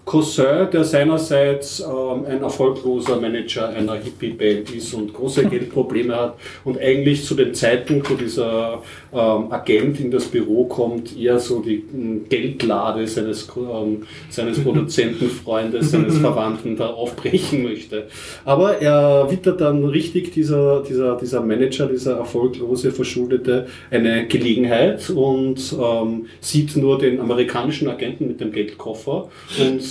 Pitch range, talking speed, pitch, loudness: 115-140 Hz, 130 wpm, 130 Hz, -19 LUFS